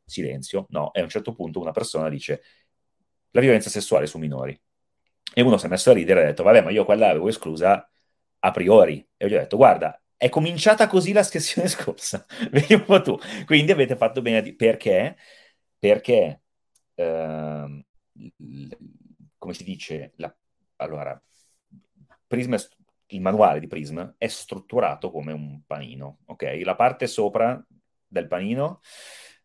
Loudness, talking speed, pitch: -21 LUFS, 155 wpm, 110 Hz